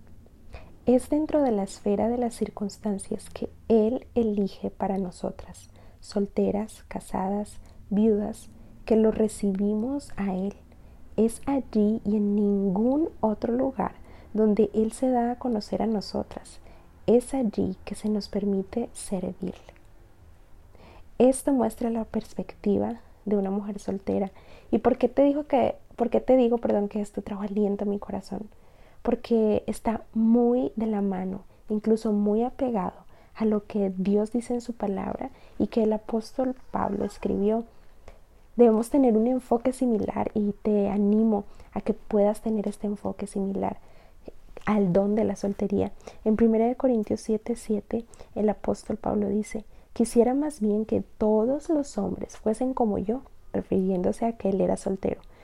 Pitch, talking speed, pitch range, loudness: 215 Hz, 150 wpm, 205-235 Hz, -26 LUFS